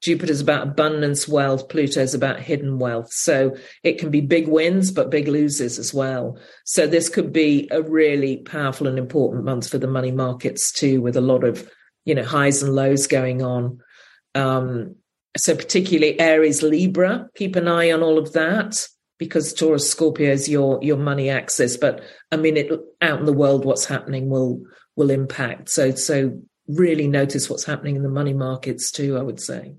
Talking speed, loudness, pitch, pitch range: 185 wpm, -20 LUFS, 145 Hz, 135-160 Hz